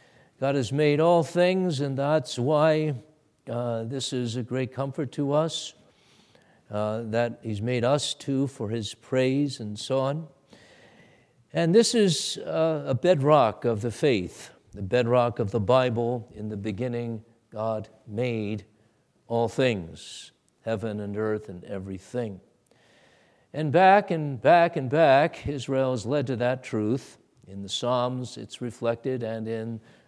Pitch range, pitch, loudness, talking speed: 115-145 Hz, 125 Hz, -26 LUFS, 145 wpm